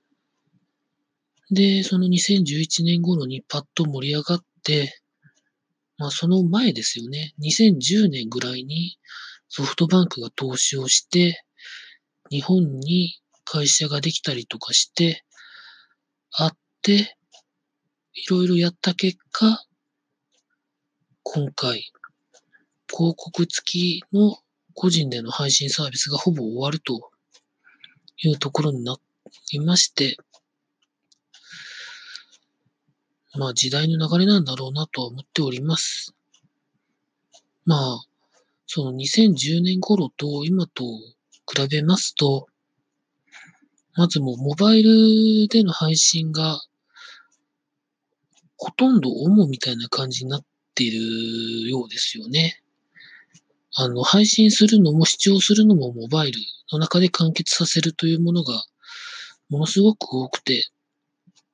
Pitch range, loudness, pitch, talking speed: 140-185 Hz, -20 LUFS, 160 Hz, 210 characters per minute